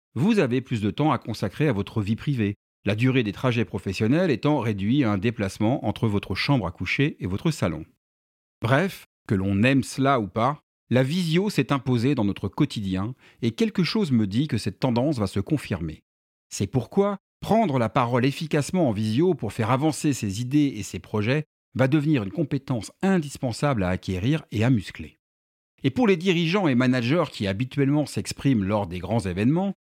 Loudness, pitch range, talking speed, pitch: -24 LUFS, 105-150 Hz, 185 wpm, 125 Hz